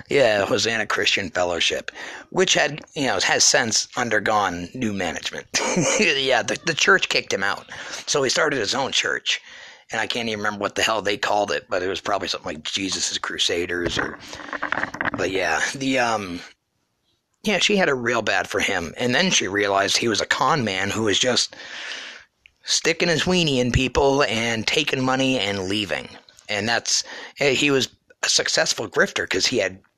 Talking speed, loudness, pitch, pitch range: 180 wpm, -21 LUFS, 110 Hz, 100-130 Hz